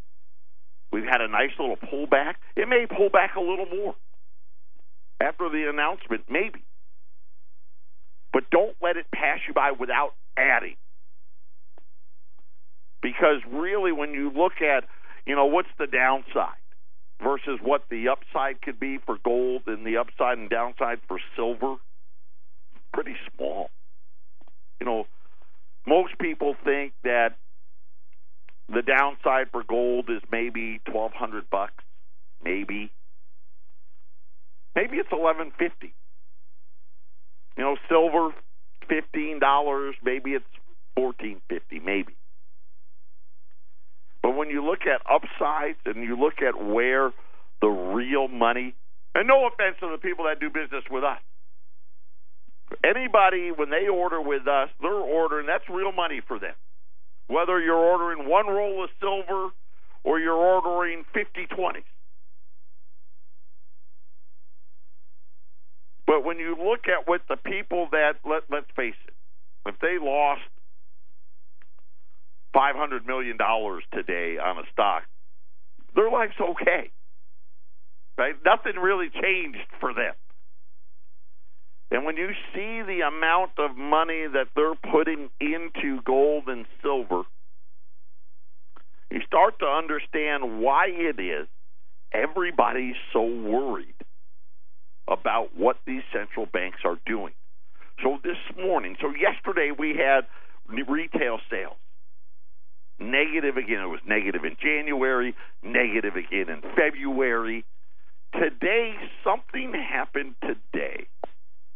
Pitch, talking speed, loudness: 125 Hz, 120 wpm, -25 LUFS